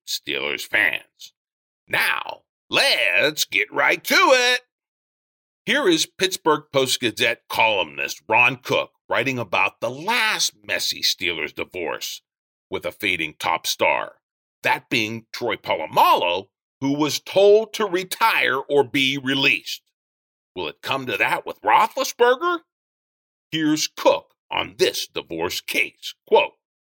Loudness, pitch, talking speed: -20 LUFS, 190 Hz, 120 wpm